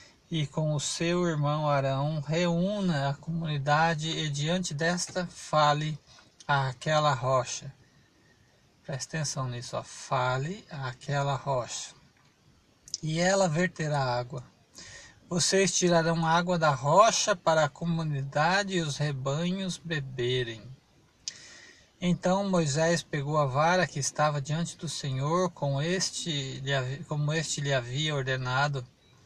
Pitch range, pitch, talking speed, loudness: 140-170 Hz, 150 Hz, 115 wpm, -28 LUFS